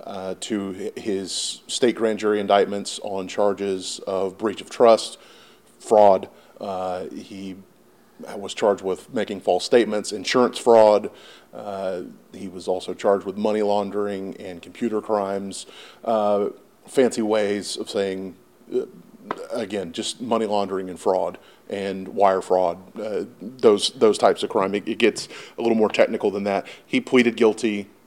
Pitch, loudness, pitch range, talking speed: 100 Hz, -22 LUFS, 95-105 Hz, 145 wpm